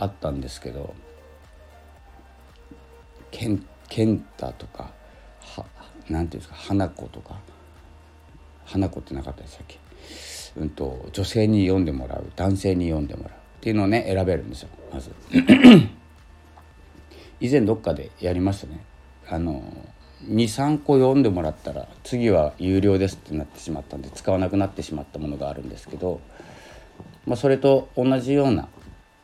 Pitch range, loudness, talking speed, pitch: 75-100 Hz, -22 LUFS, 310 characters per minute, 85 Hz